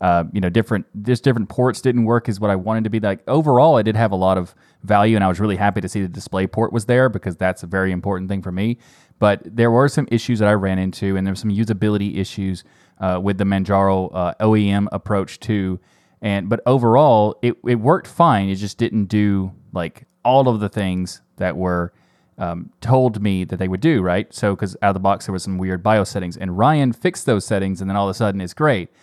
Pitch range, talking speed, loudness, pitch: 95-115 Hz, 245 wpm, -19 LUFS, 100 Hz